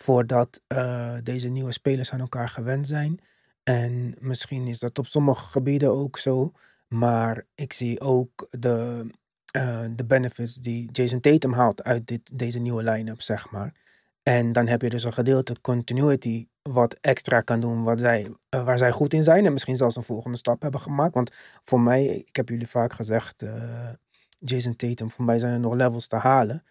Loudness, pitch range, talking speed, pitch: -24 LUFS, 120-130 Hz, 190 wpm, 125 Hz